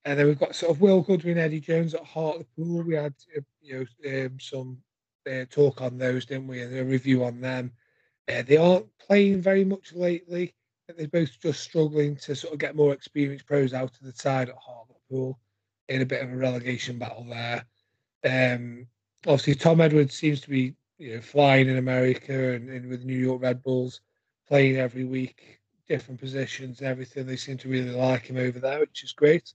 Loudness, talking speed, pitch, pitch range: -26 LUFS, 200 wpm, 130 Hz, 125-150 Hz